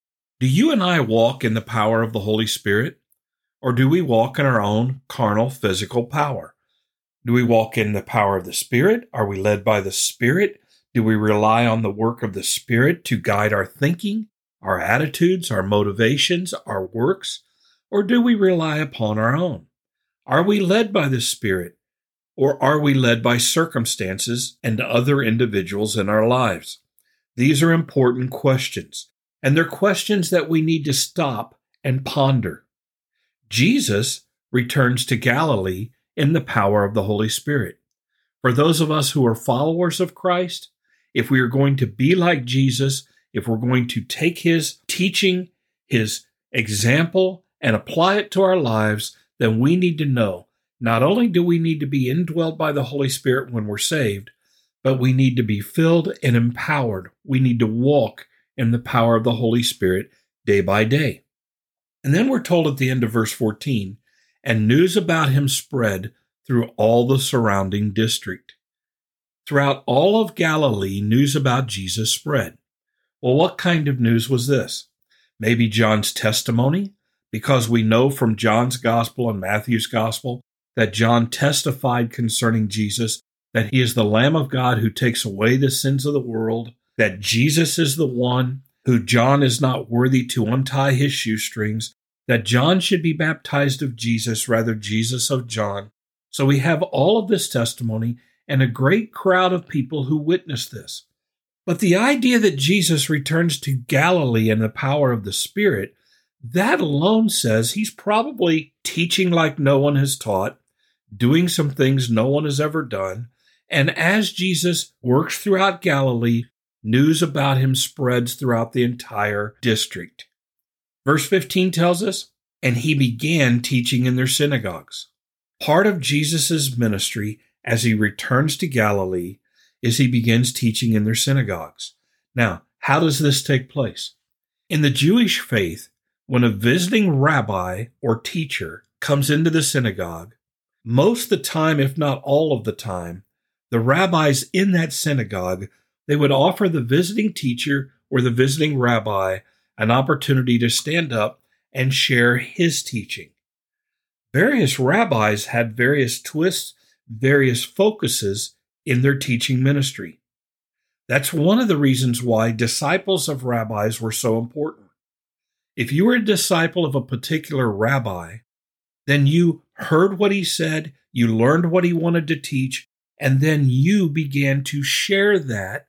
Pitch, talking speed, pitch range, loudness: 130 Hz, 160 wpm, 115-155 Hz, -19 LUFS